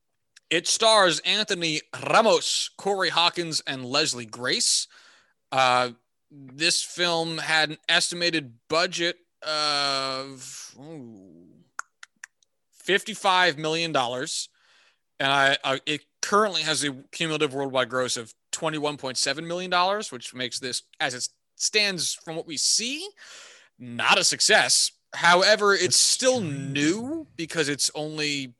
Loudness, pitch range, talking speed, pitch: -23 LUFS, 135-175 Hz, 120 wpm, 155 Hz